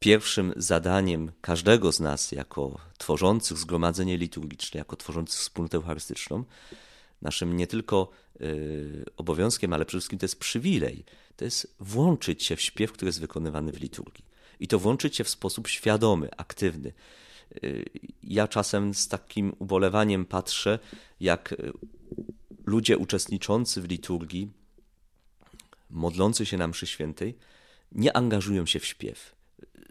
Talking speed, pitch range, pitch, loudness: 125 wpm, 80-100 Hz, 90 Hz, -28 LUFS